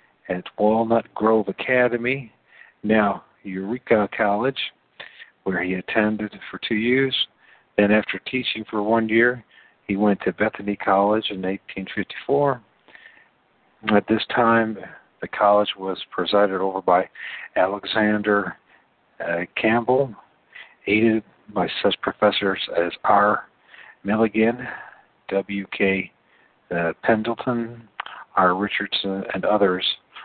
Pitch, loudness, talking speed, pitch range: 105 Hz, -22 LUFS, 105 wpm, 100-115 Hz